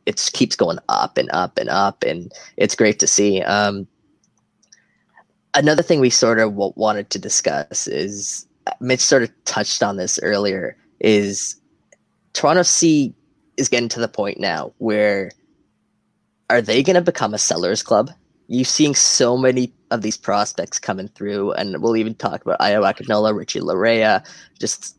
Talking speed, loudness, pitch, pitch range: 160 wpm, -18 LUFS, 110 Hz, 105-130 Hz